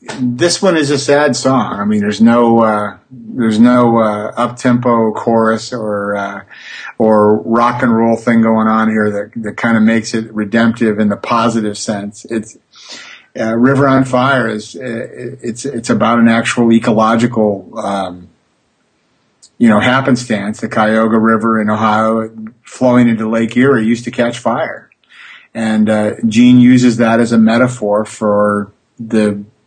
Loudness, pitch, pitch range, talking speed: -12 LUFS, 115 Hz, 110-120 Hz, 160 wpm